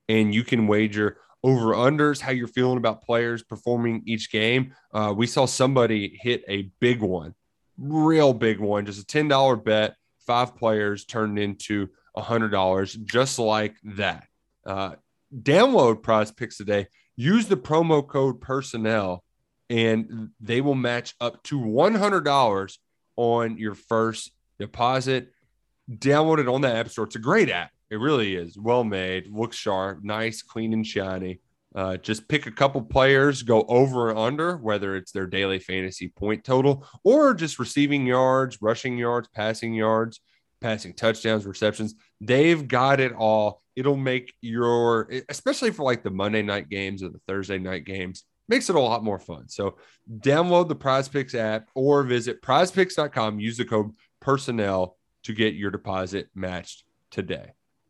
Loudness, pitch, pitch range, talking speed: -24 LUFS, 115 Hz, 105-130 Hz, 160 wpm